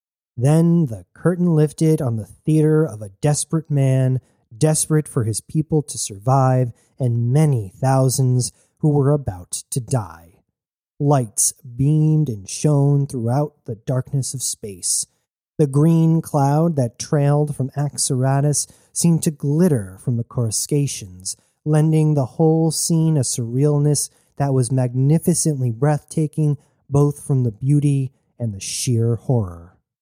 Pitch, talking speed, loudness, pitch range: 140 Hz, 130 wpm, -19 LUFS, 120-155 Hz